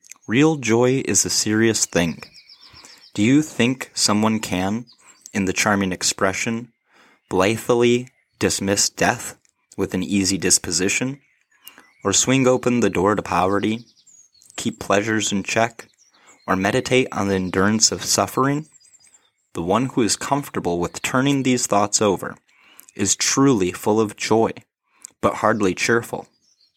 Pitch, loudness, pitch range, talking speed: 110 Hz, -20 LUFS, 95-125 Hz, 130 wpm